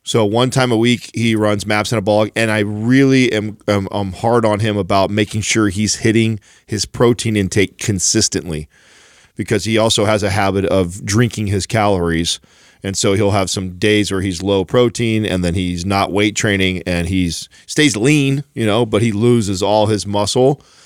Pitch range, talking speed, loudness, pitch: 100-115 Hz, 195 wpm, -16 LUFS, 105 Hz